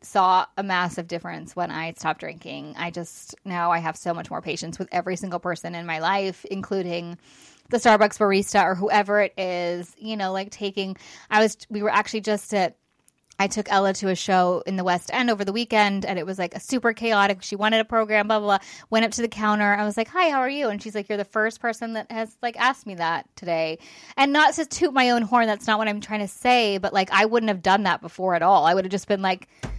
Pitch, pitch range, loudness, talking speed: 200 Hz, 180-220 Hz, -23 LUFS, 255 wpm